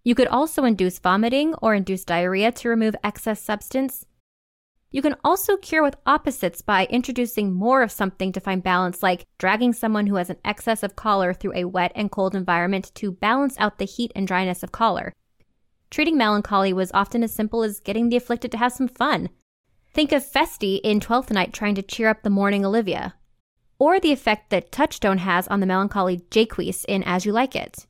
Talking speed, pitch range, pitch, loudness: 200 wpm, 190-245 Hz, 215 Hz, -22 LUFS